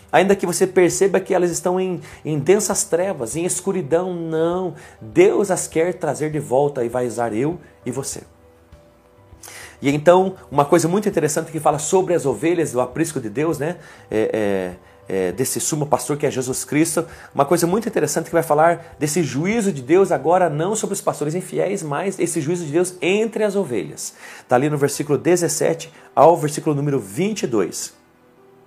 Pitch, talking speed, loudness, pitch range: 160 Hz, 180 wpm, -19 LUFS, 135-180 Hz